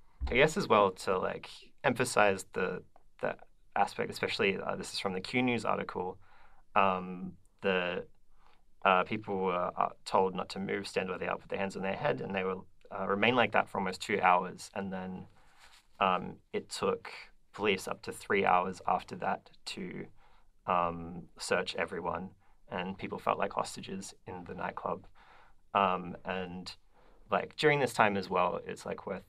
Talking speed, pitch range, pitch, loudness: 170 wpm, 90-100 Hz, 95 Hz, -32 LUFS